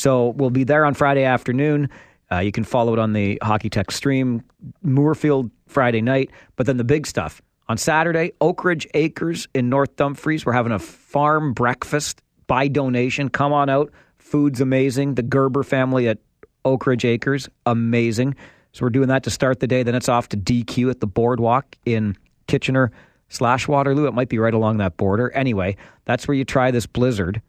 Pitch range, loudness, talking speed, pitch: 120-140 Hz, -20 LUFS, 190 wpm, 130 Hz